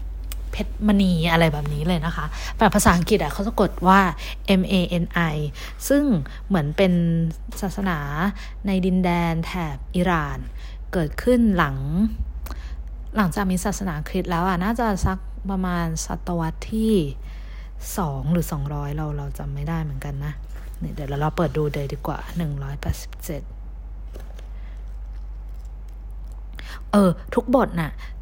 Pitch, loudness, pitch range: 170 Hz, -23 LUFS, 145-195 Hz